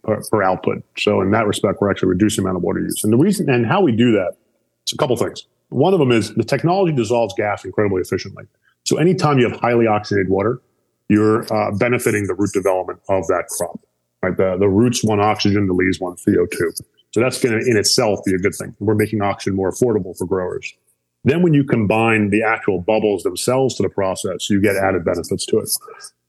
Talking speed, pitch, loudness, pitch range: 220 wpm, 110 Hz, -18 LUFS, 100-120 Hz